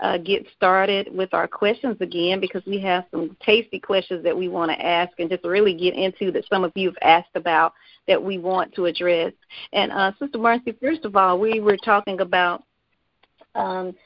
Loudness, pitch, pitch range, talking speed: -21 LUFS, 190 Hz, 180-200 Hz, 200 wpm